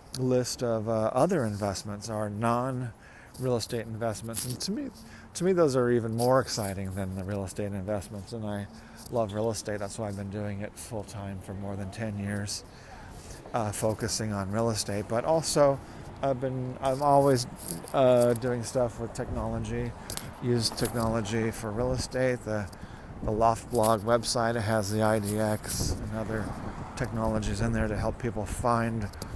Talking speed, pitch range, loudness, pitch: 165 wpm, 105-120 Hz, -29 LUFS, 110 Hz